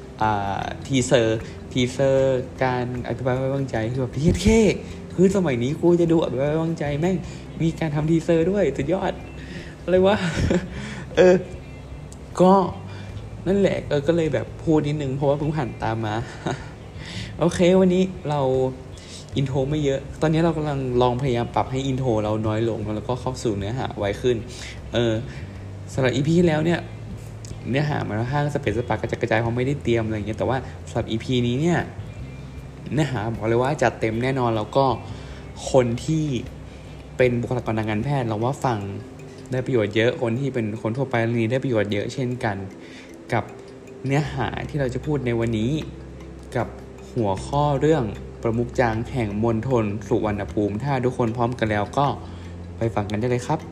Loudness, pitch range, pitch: -23 LUFS, 110-140 Hz, 125 Hz